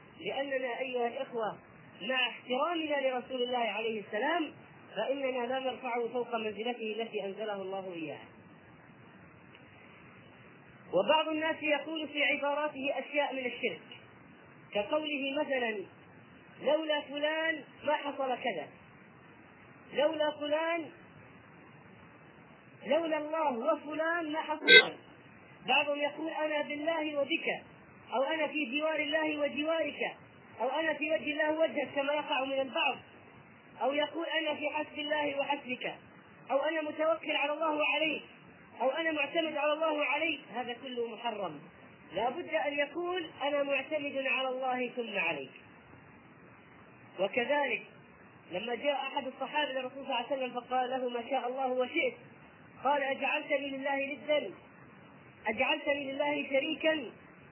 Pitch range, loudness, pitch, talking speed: 255-300 Hz, -32 LUFS, 285 Hz, 120 wpm